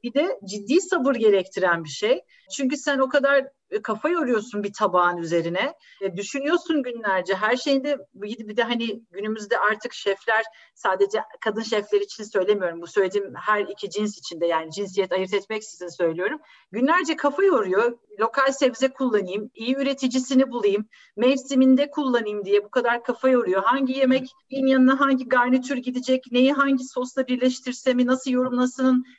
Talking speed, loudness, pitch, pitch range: 145 wpm, -23 LUFS, 245 Hz, 205-265 Hz